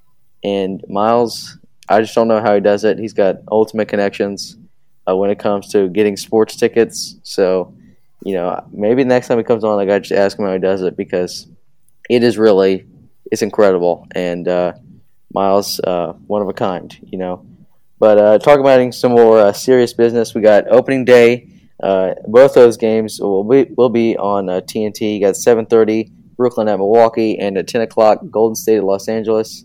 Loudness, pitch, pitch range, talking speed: -14 LUFS, 110 Hz, 100-115 Hz, 200 wpm